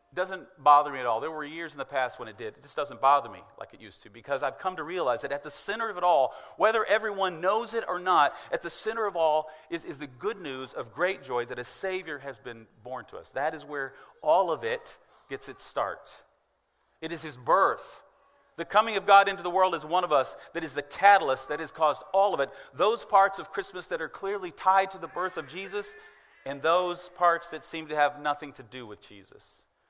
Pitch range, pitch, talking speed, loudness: 145-195 Hz, 170 Hz, 245 wpm, -28 LUFS